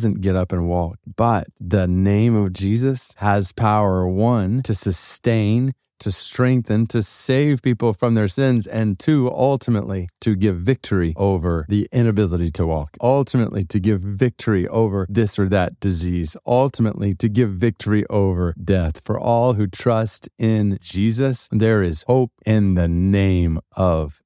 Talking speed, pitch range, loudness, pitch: 150 wpm, 95-115 Hz, -19 LUFS, 105 Hz